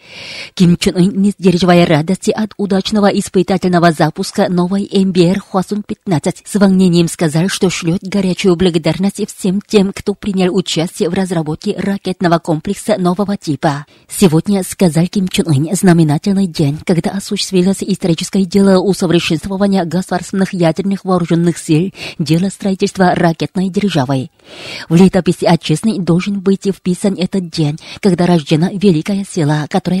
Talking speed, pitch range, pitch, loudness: 130 wpm, 170-195 Hz, 185 Hz, -14 LUFS